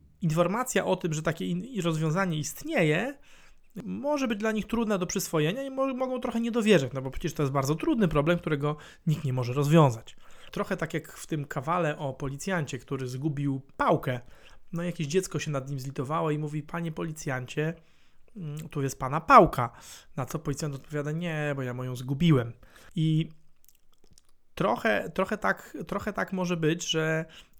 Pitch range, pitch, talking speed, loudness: 145-180 Hz, 160 Hz, 165 wpm, -28 LUFS